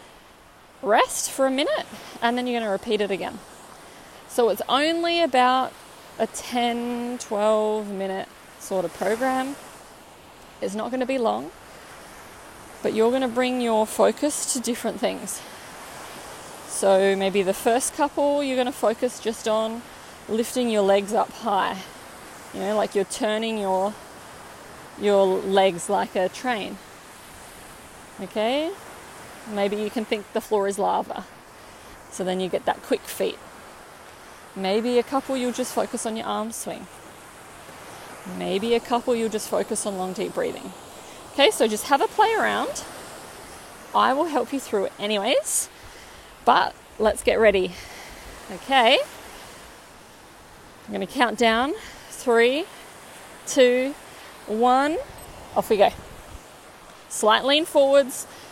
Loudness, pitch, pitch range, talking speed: -23 LUFS, 230 Hz, 210-255 Hz, 135 wpm